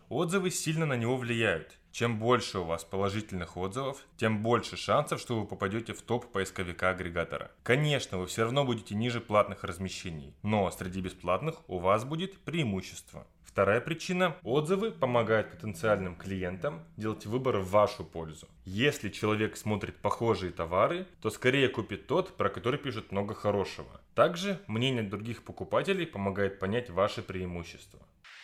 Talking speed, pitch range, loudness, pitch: 145 wpm, 95-130 Hz, -31 LUFS, 110 Hz